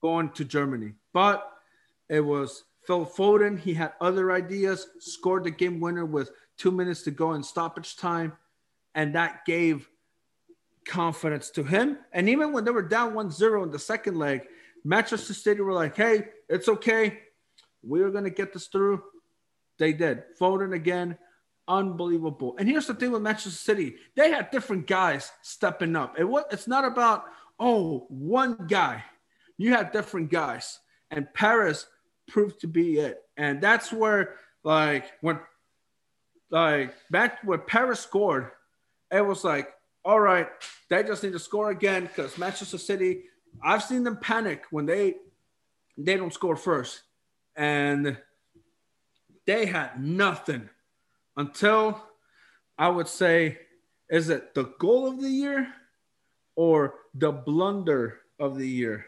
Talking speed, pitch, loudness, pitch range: 145 wpm, 185 Hz, -26 LUFS, 160-215 Hz